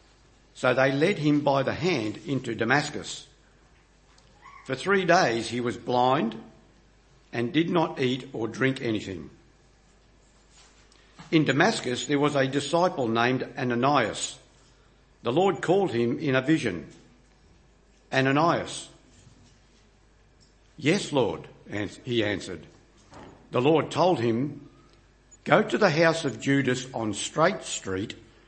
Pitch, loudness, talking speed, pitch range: 130 Hz, -25 LUFS, 115 wpm, 115-145 Hz